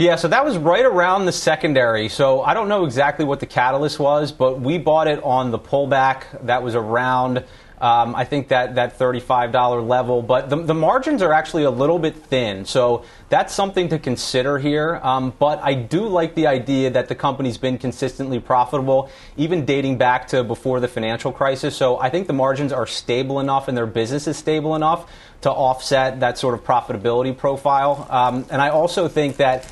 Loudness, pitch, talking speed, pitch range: -19 LUFS, 135 Hz, 200 wpm, 125-150 Hz